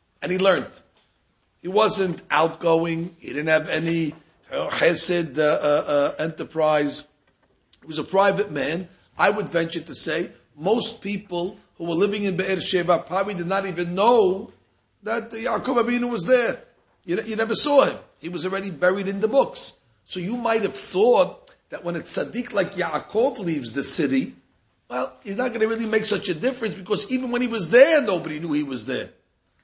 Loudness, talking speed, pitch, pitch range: -23 LUFS, 180 wpm, 190 Hz, 165-225 Hz